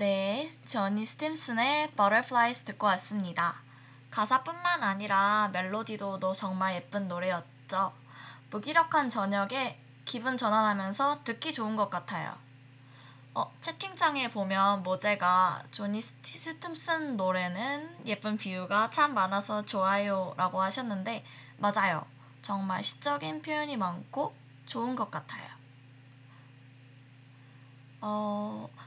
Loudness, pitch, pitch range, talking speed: -31 LUFS, 195 Hz, 140-225 Hz, 245 characters per minute